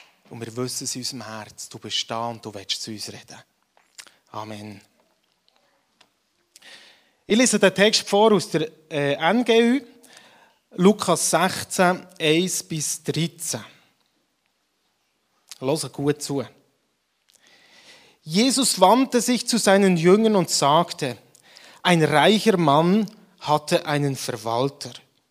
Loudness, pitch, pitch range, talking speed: -21 LUFS, 160 Hz, 130-200 Hz, 115 wpm